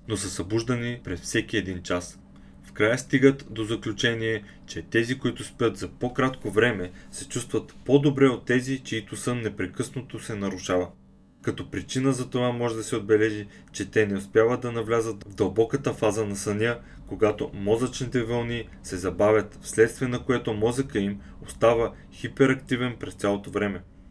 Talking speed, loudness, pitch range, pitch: 155 wpm, -26 LUFS, 100-125 Hz, 115 Hz